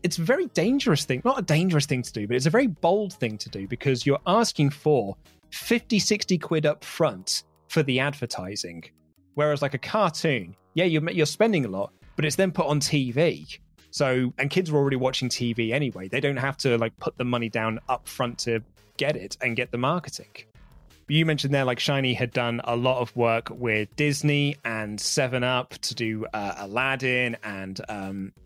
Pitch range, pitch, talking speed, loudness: 115-155 Hz, 130 Hz, 200 wpm, -25 LUFS